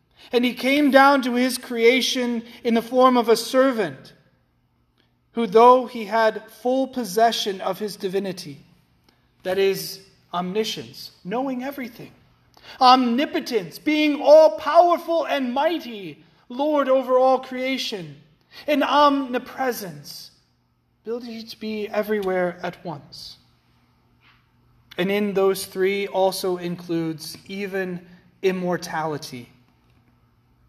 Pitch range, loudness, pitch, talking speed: 180-255 Hz, -21 LUFS, 215 Hz, 105 wpm